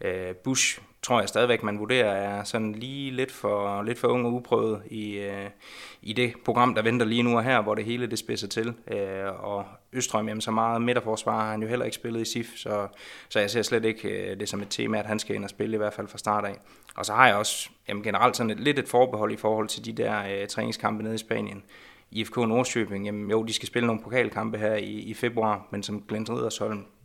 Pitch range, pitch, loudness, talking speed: 105-115 Hz, 110 Hz, -27 LUFS, 240 wpm